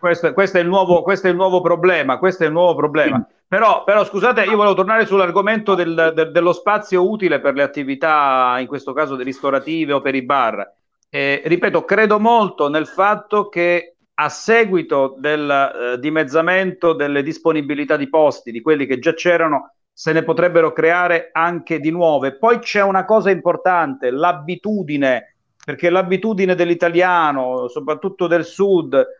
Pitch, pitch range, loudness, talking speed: 170 Hz, 150-190 Hz, -16 LUFS, 160 wpm